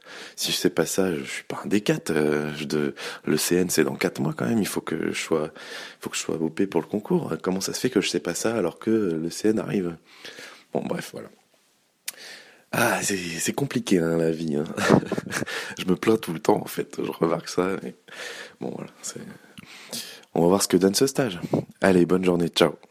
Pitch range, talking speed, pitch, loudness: 80-100 Hz, 235 wpm, 85 Hz, -25 LUFS